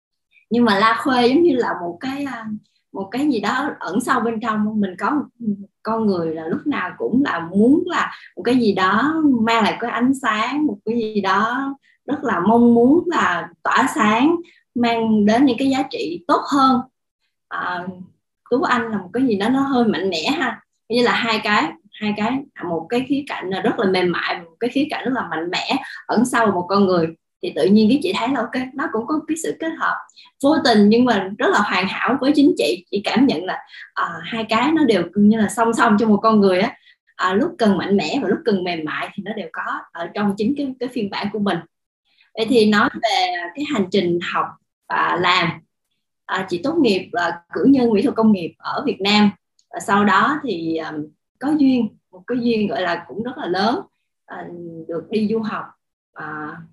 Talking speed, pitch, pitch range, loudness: 225 wpm, 225 Hz, 200-265 Hz, -19 LUFS